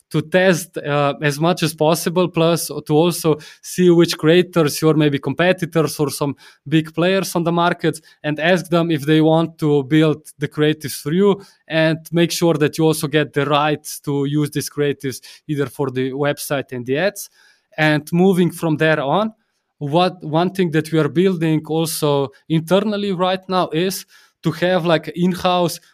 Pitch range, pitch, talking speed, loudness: 150-175 Hz, 160 Hz, 180 wpm, -18 LUFS